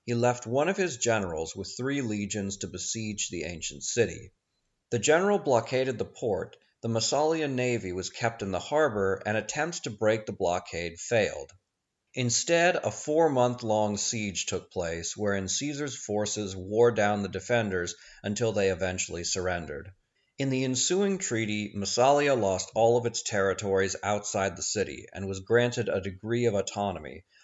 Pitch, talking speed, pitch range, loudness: 105 Hz, 155 wpm, 95-125 Hz, -28 LUFS